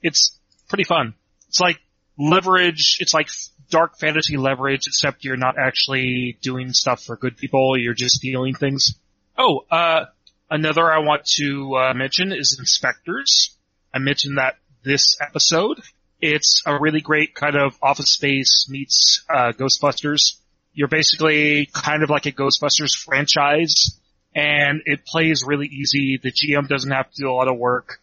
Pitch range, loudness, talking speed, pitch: 130-150 Hz, -17 LUFS, 155 wpm, 140 Hz